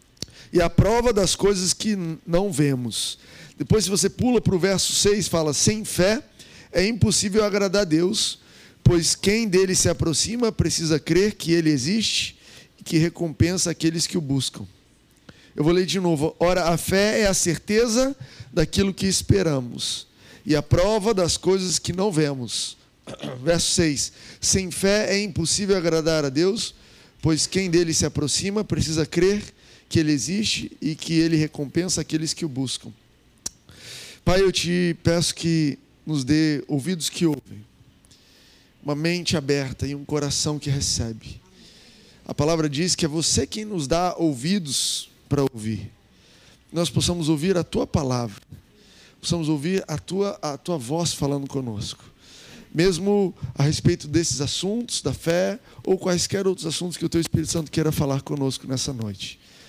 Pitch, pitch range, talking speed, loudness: 165 Hz, 145-185 Hz, 155 wpm, -22 LUFS